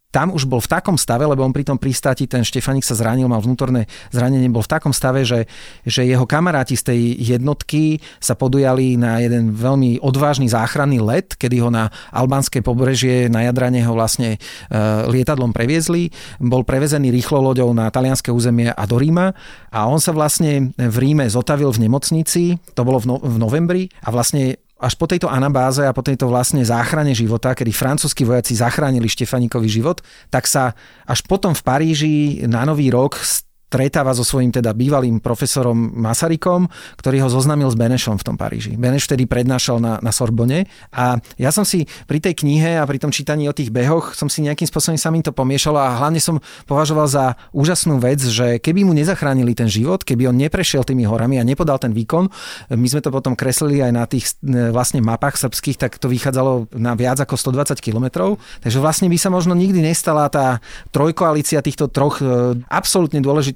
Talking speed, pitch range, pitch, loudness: 185 wpm, 120-150 Hz, 130 Hz, -17 LUFS